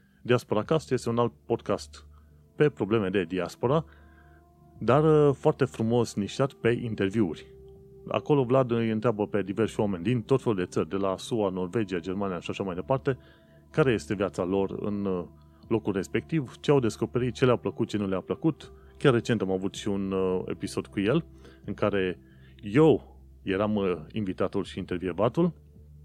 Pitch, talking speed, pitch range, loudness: 100 Hz, 160 wpm, 90-120 Hz, -28 LUFS